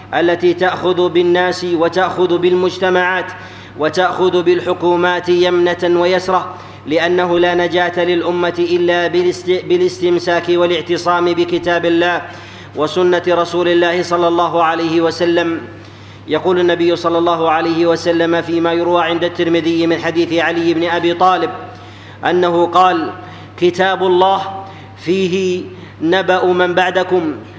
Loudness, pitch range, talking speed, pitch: -14 LUFS, 170-180 Hz, 105 wpm, 175 Hz